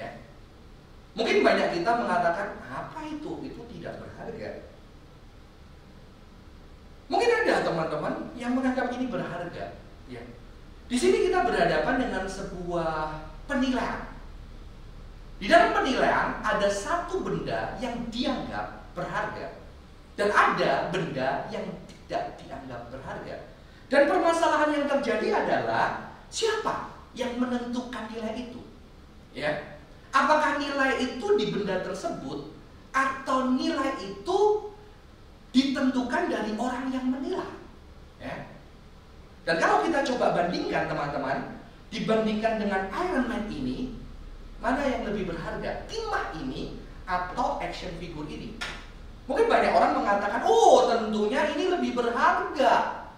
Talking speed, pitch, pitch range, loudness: 110 wpm, 255 Hz, 220-310 Hz, -27 LUFS